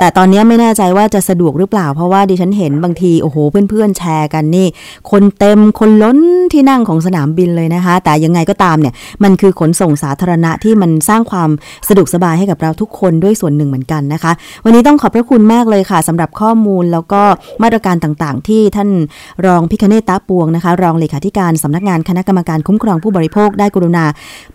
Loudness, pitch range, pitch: -10 LUFS, 165-205 Hz, 185 Hz